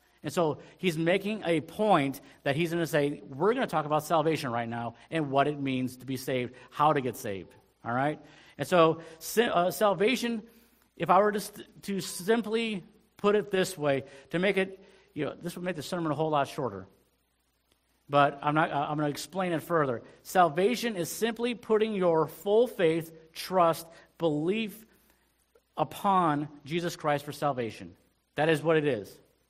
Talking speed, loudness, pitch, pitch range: 185 wpm, -29 LUFS, 165 Hz, 145-195 Hz